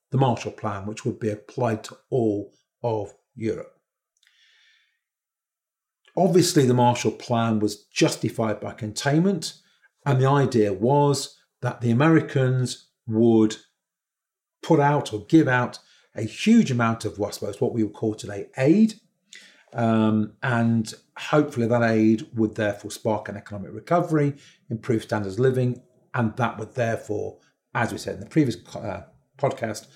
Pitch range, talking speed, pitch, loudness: 110-145 Hz, 140 wpm, 120 Hz, -23 LUFS